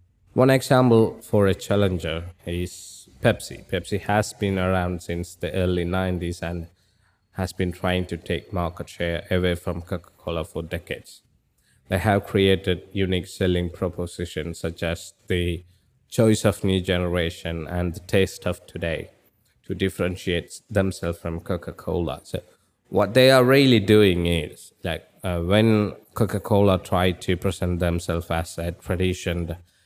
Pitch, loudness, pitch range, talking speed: 90 Hz, -23 LUFS, 85-100 Hz, 140 wpm